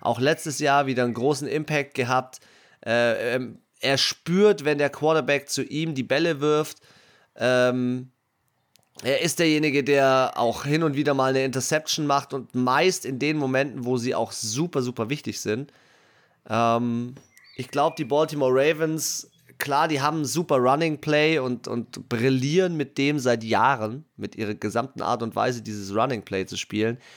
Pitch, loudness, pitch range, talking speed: 135 Hz, -24 LUFS, 120-150 Hz, 165 wpm